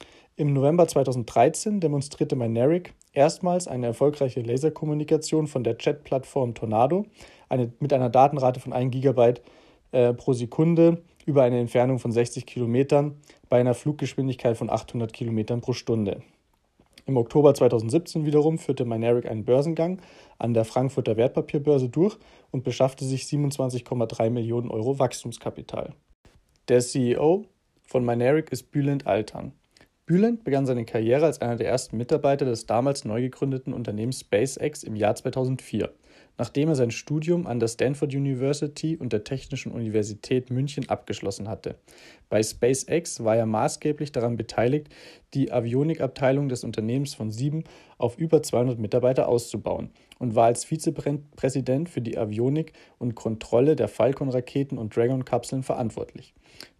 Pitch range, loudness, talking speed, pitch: 120-150 Hz, -25 LUFS, 135 wpm, 130 Hz